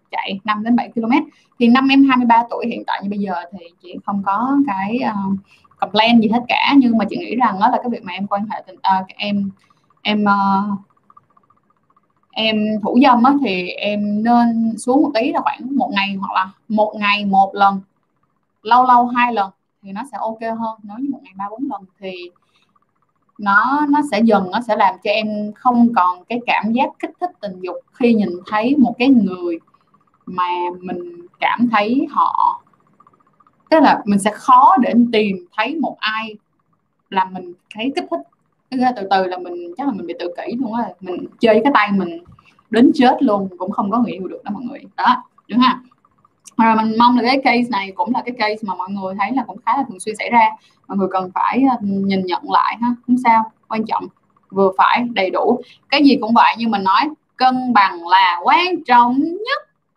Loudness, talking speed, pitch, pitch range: -16 LUFS, 205 wpm, 220 Hz, 195-255 Hz